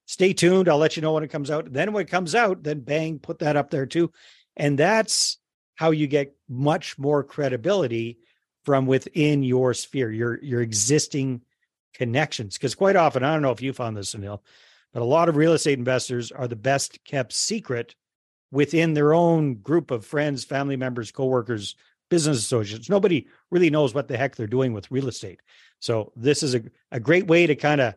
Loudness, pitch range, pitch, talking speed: -23 LUFS, 125-155 Hz, 140 Hz, 200 wpm